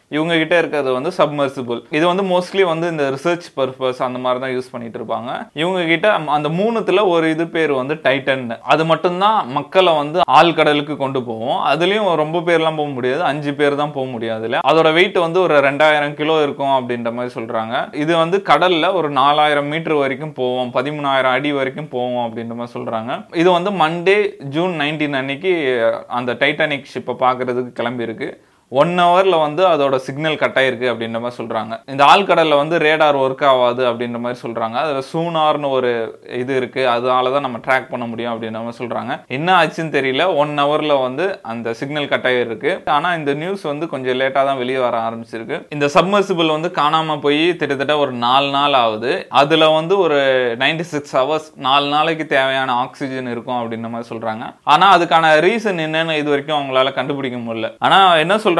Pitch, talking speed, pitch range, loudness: 140 Hz, 175 wpm, 125-160 Hz, -16 LUFS